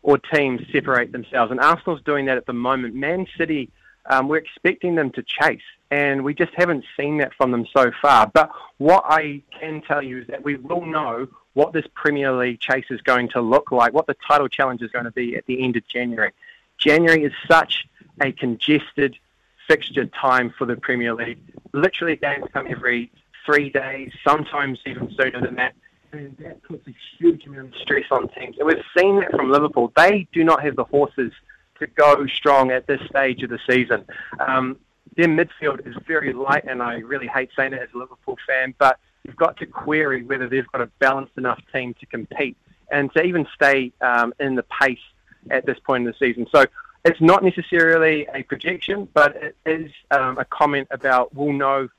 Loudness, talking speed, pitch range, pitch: -20 LUFS, 200 wpm, 125-155 Hz, 140 Hz